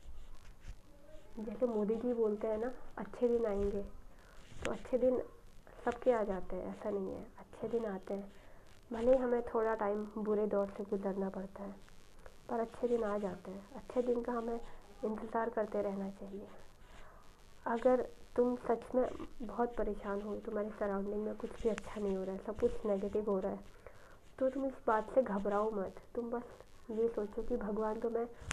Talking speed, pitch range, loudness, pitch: 180 wpm, 205-235 Hz, -37 LUFS, 220 Hz